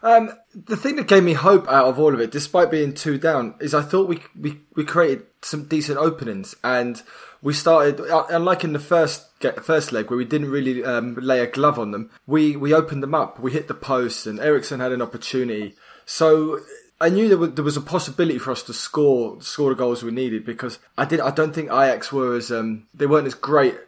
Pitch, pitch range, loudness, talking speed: 150 Hz, 125-165 Hz, -20 LUFS, 230 wpm